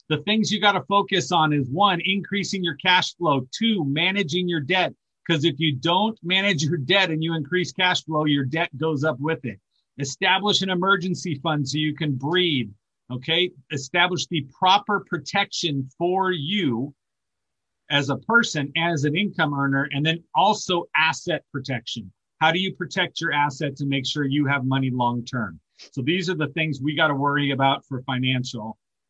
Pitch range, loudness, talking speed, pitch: 140-180 Hz, -22 LUFS, 180 wpm, 160 Hz